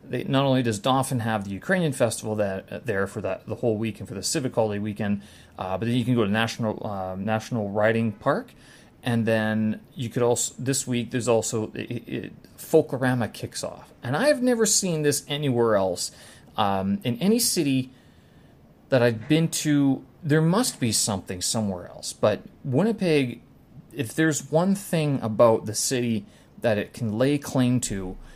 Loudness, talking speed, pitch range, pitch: -25 LUFS, 175 wpm, 110-140 Hz, 120 Hz